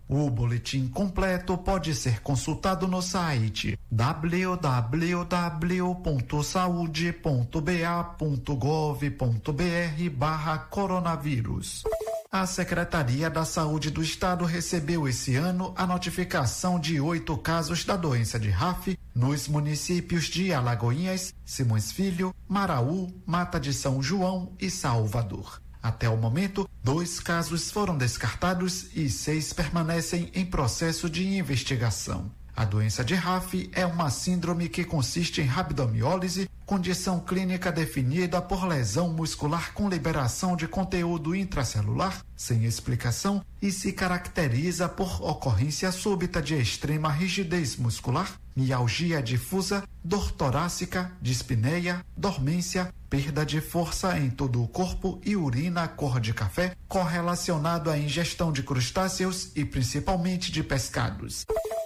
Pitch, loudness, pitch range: 170 Hz, -28 LUFS, 135-180 Hz